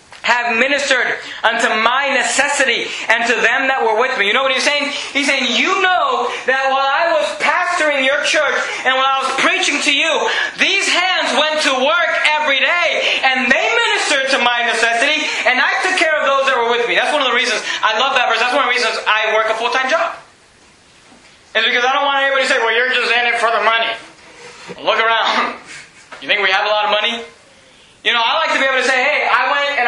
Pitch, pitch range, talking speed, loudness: 270 Hz, 235-295 Hz, 230 wpm, -14 LUFS